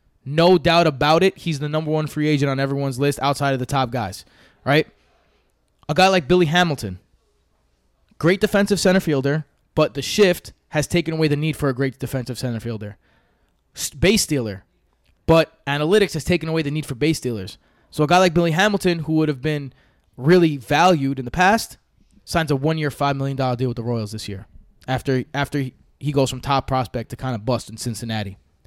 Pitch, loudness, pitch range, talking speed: 140 Hz, -20 LUFS, 125-160 Hz, 195 wpm